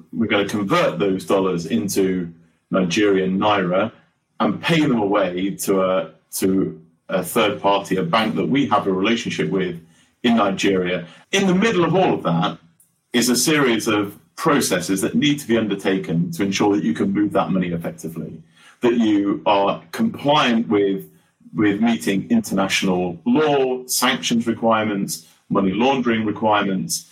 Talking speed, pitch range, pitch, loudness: 155 wpm, 90-115 Hz, 100 Hz, -19 LUFS